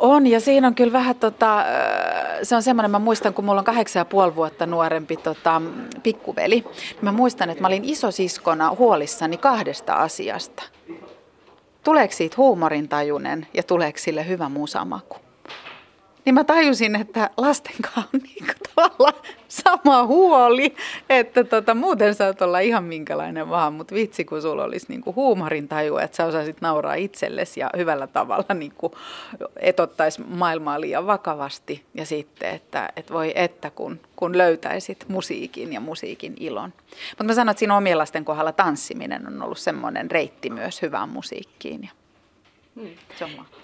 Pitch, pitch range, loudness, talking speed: 200 Hz, 160-245 Hz, -21 LUFS, 150 wpm